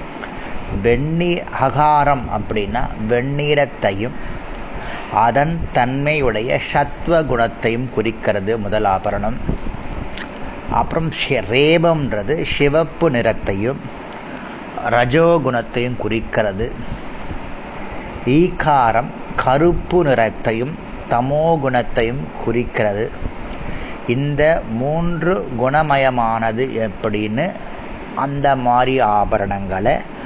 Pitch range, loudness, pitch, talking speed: 115-150 Hz, -18 LUFS, 125 Hz, 60 wpm